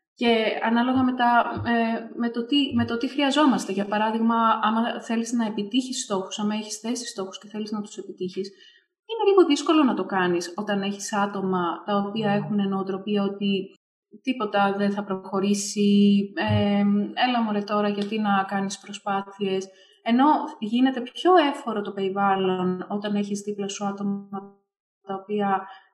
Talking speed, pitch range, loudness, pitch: 155 wpm, 195-235 Hz, -24 LUFS, 205 Hz